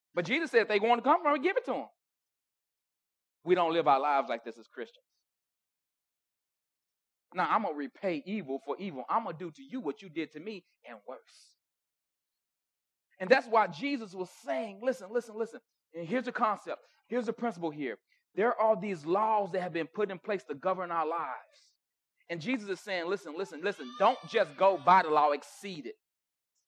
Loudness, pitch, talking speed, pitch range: -31 LUFS, 200 Hz, 200 wpm, 170-240 Hz